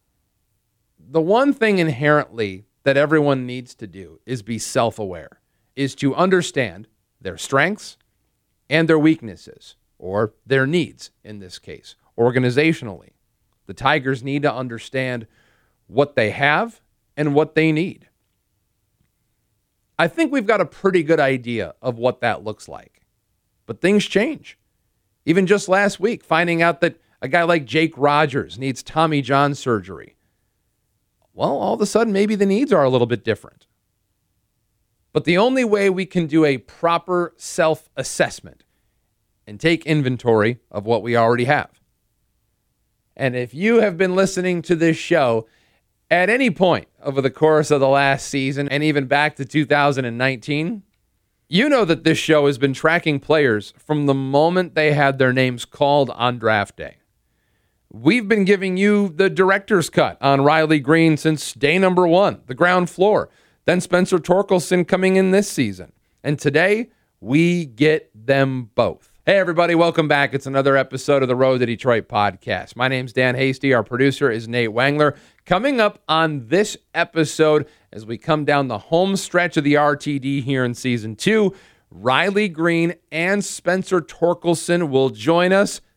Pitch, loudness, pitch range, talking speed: 145 Hz, -18 LUFS, 120-170 Hz, 160 wpm